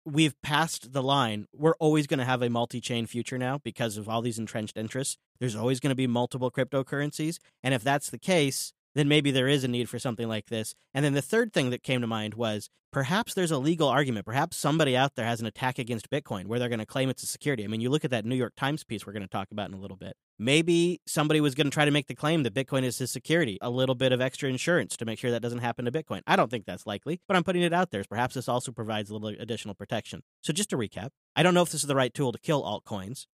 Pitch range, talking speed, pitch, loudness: 115-150 Hz, 285 wpm, 130 Hz, -28 LUFS